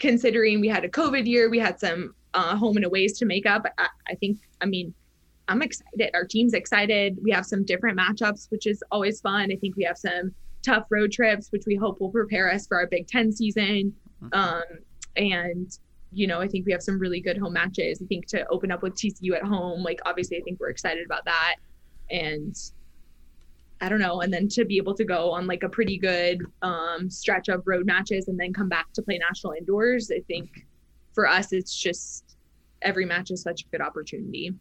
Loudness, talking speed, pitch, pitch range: -25 LUFS, 220 wpm, 190 Hz, 175-210 Hz